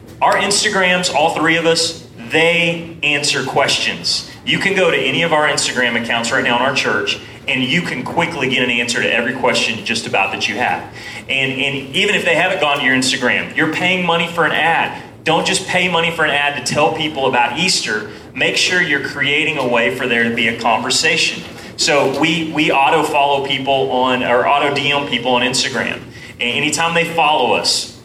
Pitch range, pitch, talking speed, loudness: 125-165 Hz, 140 Hz, 205 wpm, -15 LUFS